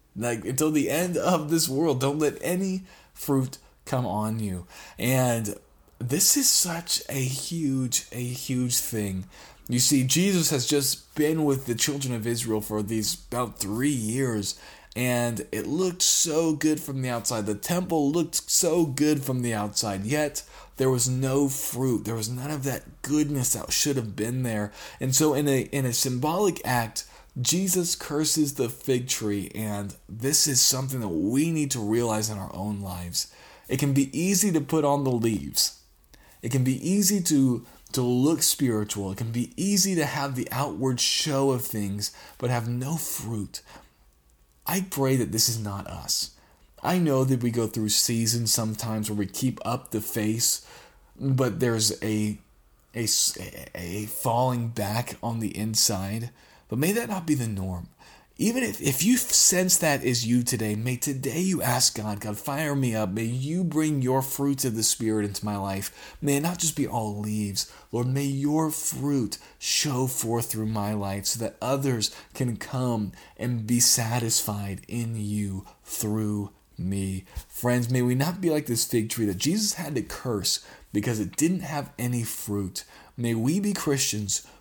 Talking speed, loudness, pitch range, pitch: 175 wpm, -25 LUFS, 110-145 Hz, 125 Hz